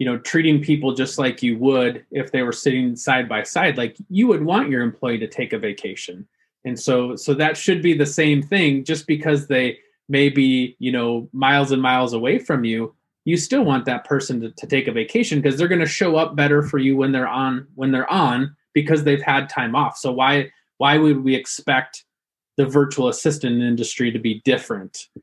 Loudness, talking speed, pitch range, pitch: -19 LUFS, 215 wpm, 125-150 Hz, 135 Hz